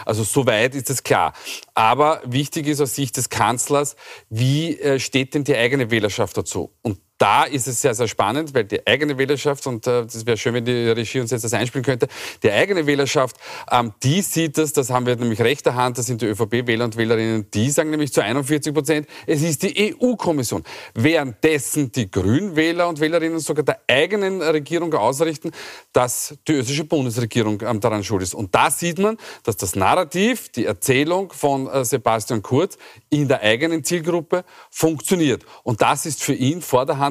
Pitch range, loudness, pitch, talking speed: 120-160 Hz, -20 LUFS, 140 Hz, 180 wpm